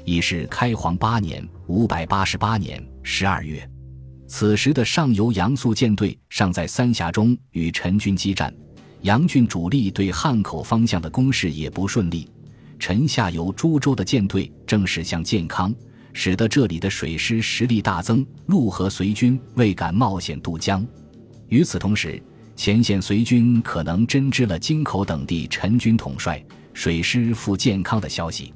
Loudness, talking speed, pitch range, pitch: -21 LUFS, 235 characters per minute, 85-120 Hz, 100 Hz